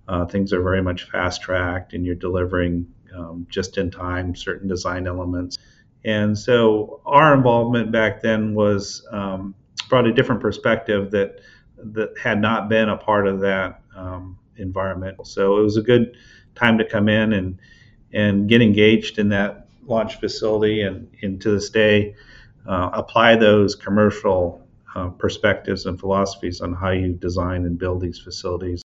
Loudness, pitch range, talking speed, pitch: -20 LUFS, 90-110 Hz, 160 wpm, 100 Hz